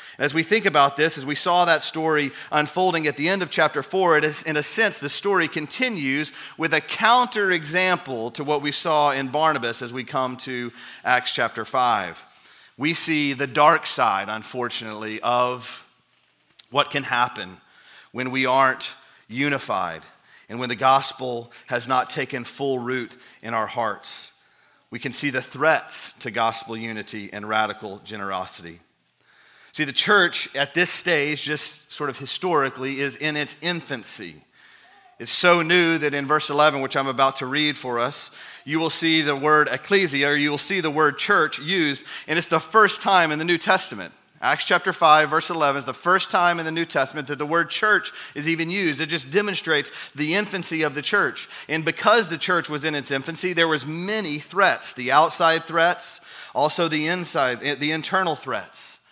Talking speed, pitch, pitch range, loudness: 180 wpm, 150 Hz, 130-165 Hz, -21 LUFS